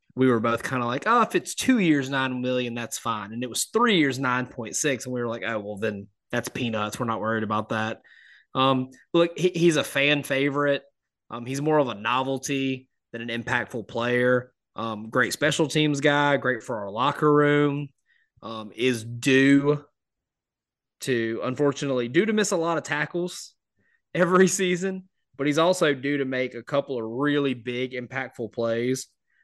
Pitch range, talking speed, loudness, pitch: 120-145 Hz, 180 wpm, -24 LUFS, 130 Hz